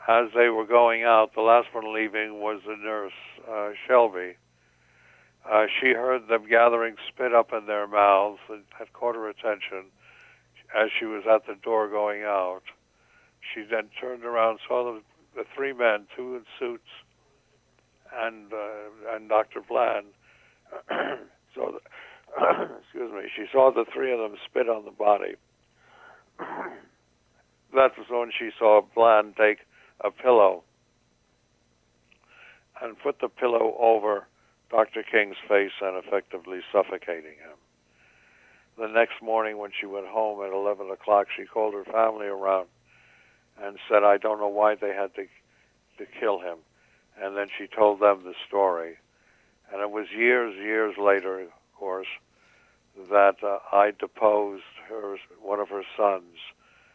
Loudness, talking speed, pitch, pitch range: -25 LUFS, 150 wpm, 105 Hz, 95-110 Hz